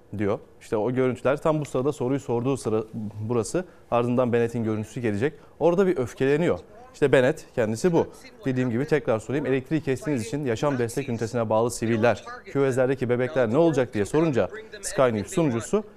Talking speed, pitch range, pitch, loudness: 160 wpm, 115-150 Hz, 130 Hz, -25 LUFS